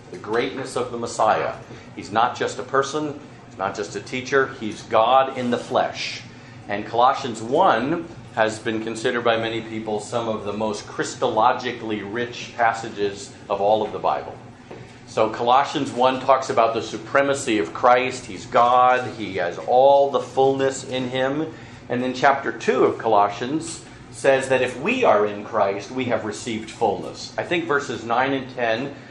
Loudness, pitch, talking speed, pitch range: -22 LUFS, 120 Hz, 170 wpm, 110-130 Hz